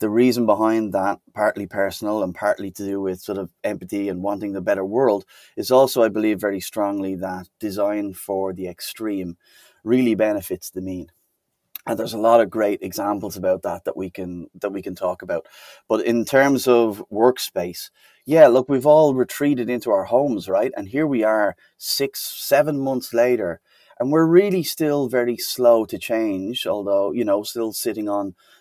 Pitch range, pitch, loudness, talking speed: 100-125 Hz, 110 Hz, -21 LUFS, 180 wpm